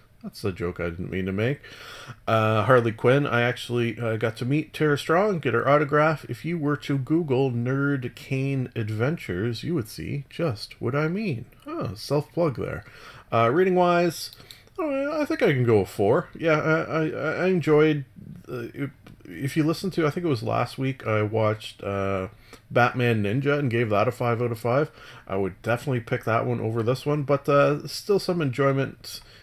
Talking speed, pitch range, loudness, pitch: 195 wpm, 115-150 Hz, -25 LUFS, 130 Hz